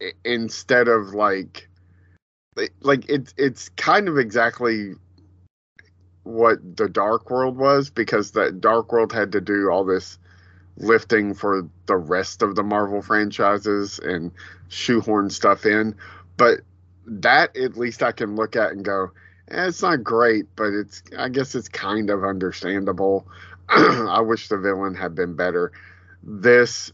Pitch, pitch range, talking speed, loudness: 100 Hz, 90-115 Hz, 145 wpm, -21 LUFS